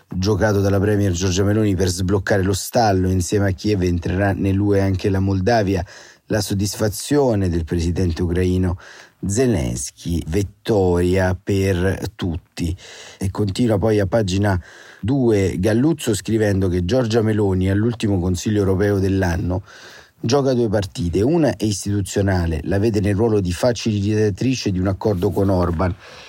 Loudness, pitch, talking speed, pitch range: -19 LUFS, 100 Hz, 130 wpm, 95-110 Hz